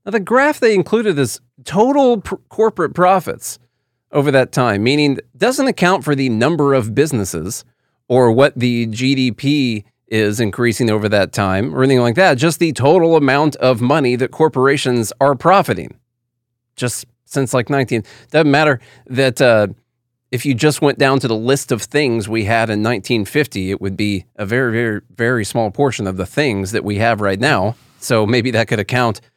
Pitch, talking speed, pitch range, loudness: 125 Hz, 180 wpm, 115-145 Hz, -15 LUFS